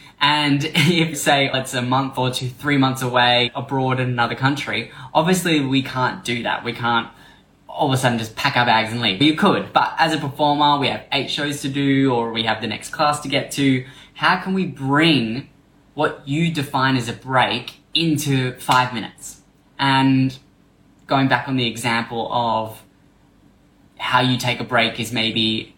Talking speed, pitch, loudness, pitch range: 185 wpm, 130 Hz, -19 LUFS, 120-145 Hz